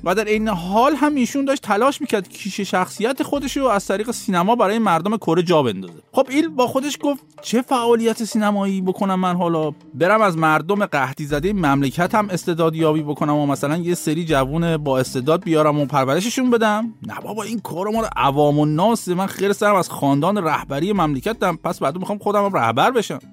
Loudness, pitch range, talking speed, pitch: -19 LUFS, 155-220 Hz, 190 wpm, 190 Hz